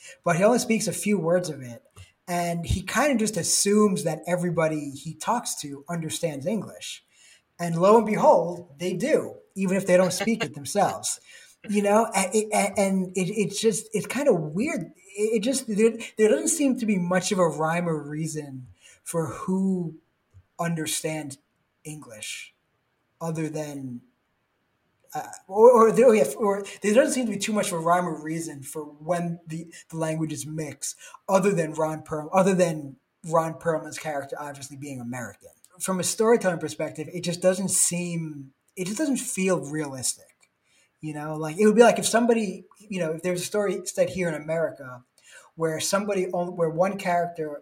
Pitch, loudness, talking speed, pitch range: 175 Hz, -24 LUFS, 170 wpm, 155-205 Hz